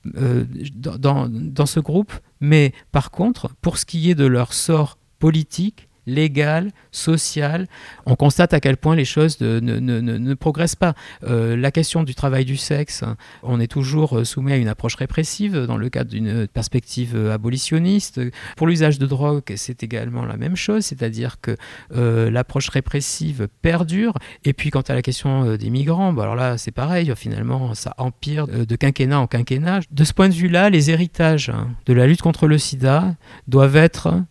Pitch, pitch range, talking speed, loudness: 140 Hz, 120-160 Hz, 185 wpm, -19 LUFS